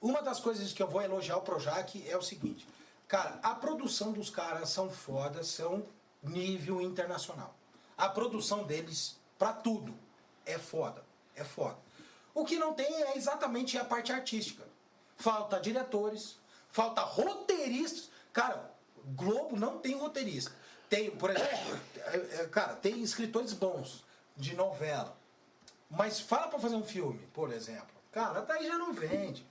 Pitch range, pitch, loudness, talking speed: 185-255 Hz, 215 Hz, -36 LUFS, 145 wpm